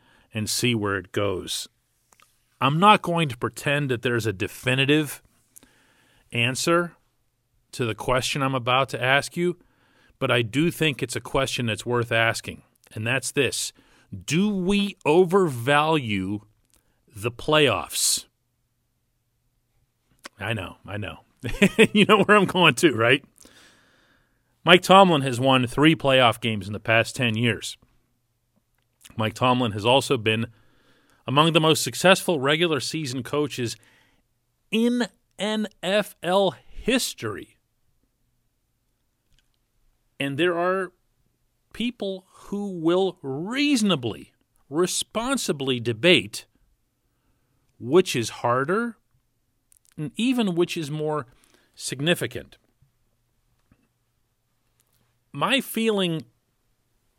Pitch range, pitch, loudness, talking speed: 120-170 Hz, 130 Hz, -22 LUFS, 105 wpm